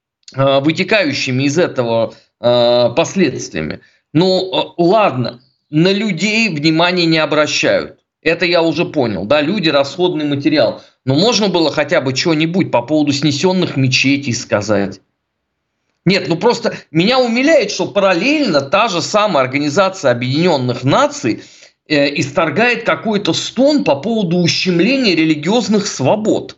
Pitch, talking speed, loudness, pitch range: 165 Hz, 115 wpm, -14 LUFS, 140-200 Hz